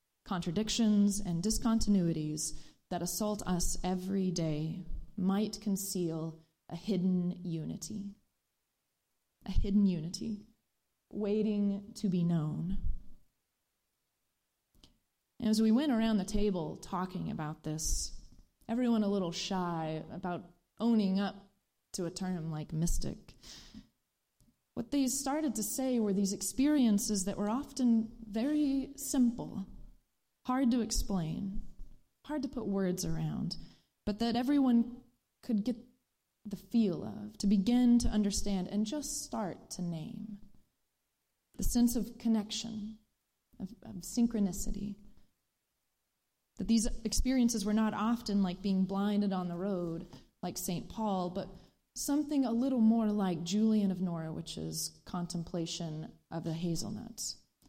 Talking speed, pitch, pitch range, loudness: 120 wpm, 205 Hz, 180-225 Hz, -34 LUFS